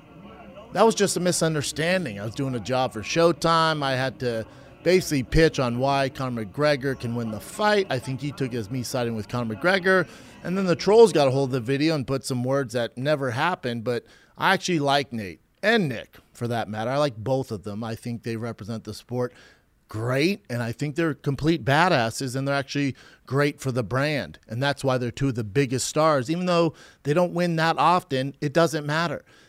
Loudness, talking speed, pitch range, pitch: -24 LUFS, 220 wpm, 125-160 Hz, 140 Hz